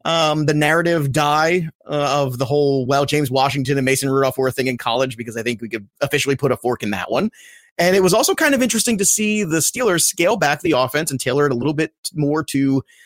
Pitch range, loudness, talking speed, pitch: 135-165 Hz, -18 LUFS, 250 wpm, 145 Hz